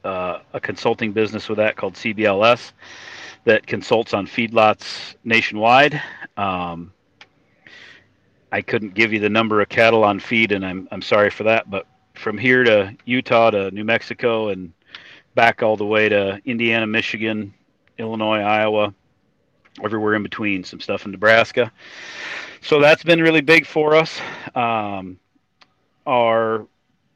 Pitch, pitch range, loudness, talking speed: 110 Hz, 100-115 Hz, -18 LUFS, 140 wpm